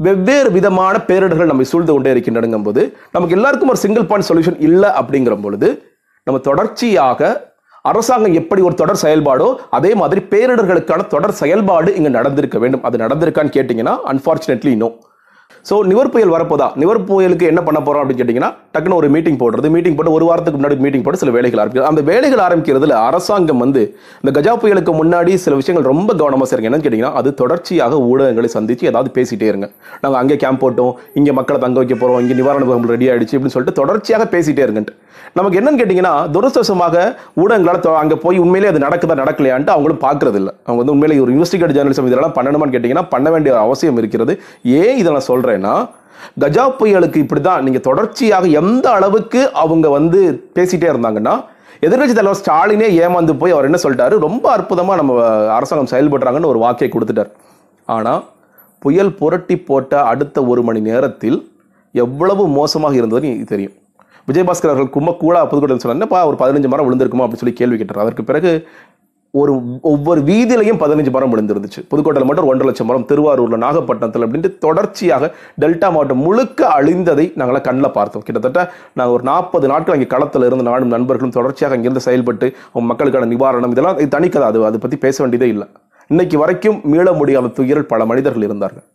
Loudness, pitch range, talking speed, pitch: -13 LUFS, 125-180 Hz, 160 wpm, 150 Hz